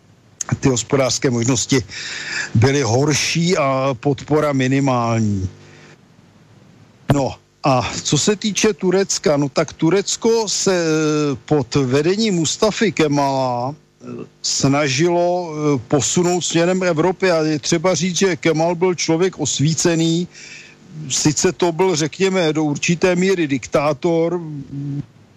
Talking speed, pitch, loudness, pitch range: 100 wpm, 155 Hz, -17 LUFS, 140-180 Hz